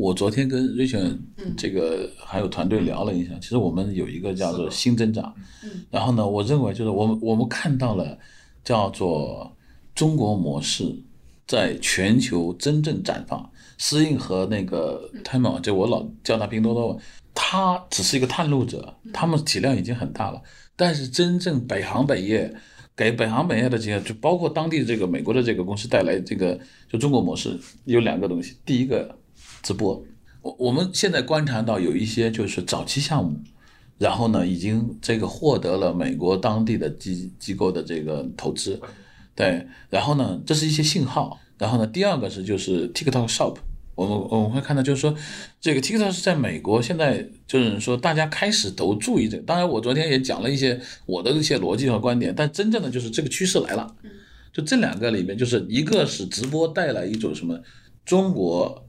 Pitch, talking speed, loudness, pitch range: 120 Hz, 300 characters per minute, -23 LUFS, 105-150 Hz